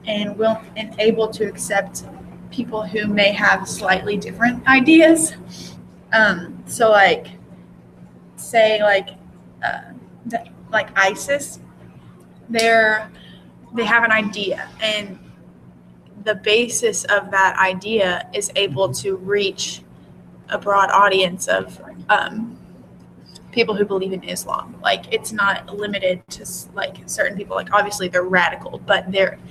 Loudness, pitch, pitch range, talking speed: -18 LUFS, 200 Hz, 135-215 Hz, 125 wpm